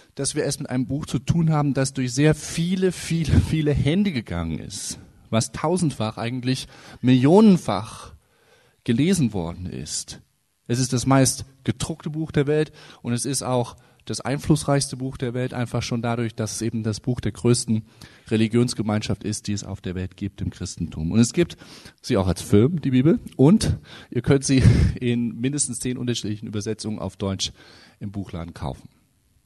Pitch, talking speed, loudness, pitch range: 120 Hz, 175 wpm, -23 LUFS, 105-140 Hz